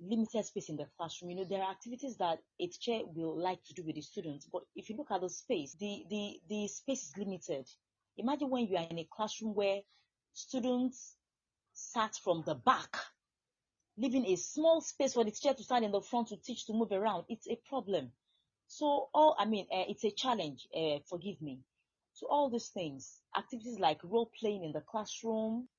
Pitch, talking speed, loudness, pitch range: 210 Hz, 205 wpm, -36 LUFS, 180-245 Hz